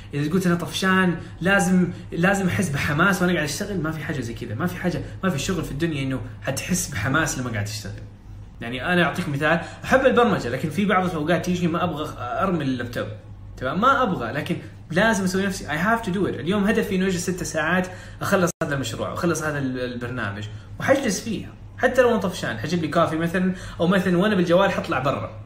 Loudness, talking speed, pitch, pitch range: -23 LUFS, 200 wpm, 165 Hz, 130-185 Hz